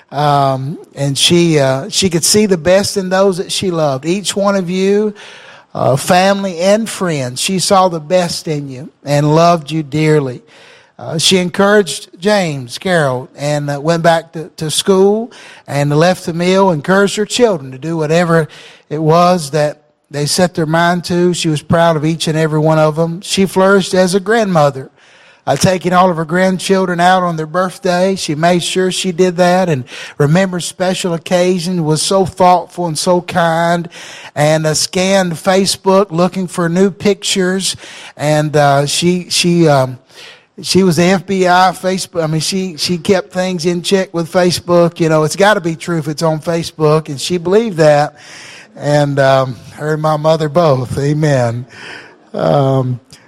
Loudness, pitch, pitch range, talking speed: -13 LUFS, 175 Hz, 155-185 Hz, 175 wpm